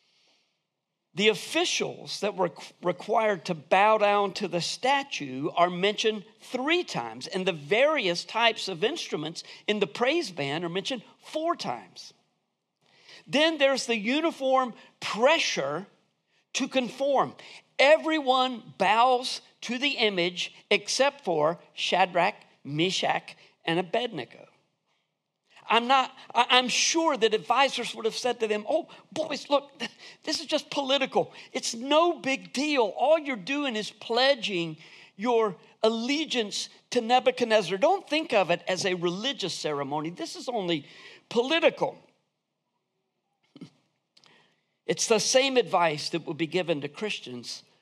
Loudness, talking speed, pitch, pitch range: -26 LUFS, 125 wpm, 225 Hz, 180-270 Hz